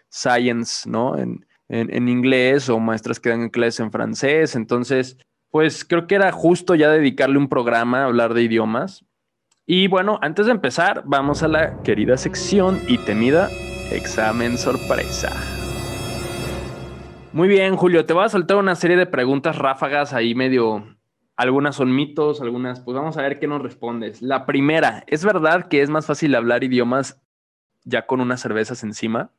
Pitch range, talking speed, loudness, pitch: 120-155 Hz, 165 wpm, -19 LUFS, 130 Hz